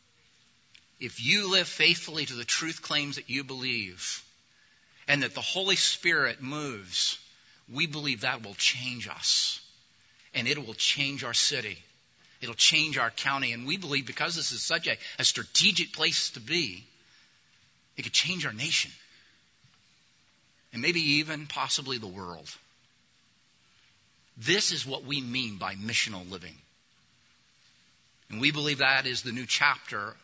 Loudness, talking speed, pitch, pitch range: -27 LUFS, 145 wpm, 135 Hz, 115-150 Hz